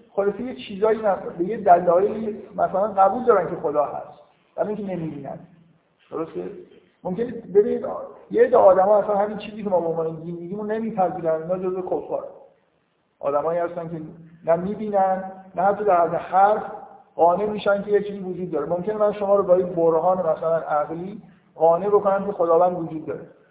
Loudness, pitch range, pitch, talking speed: -22 LUFS, 170-205 Hz, 190 Hz, 175 wpm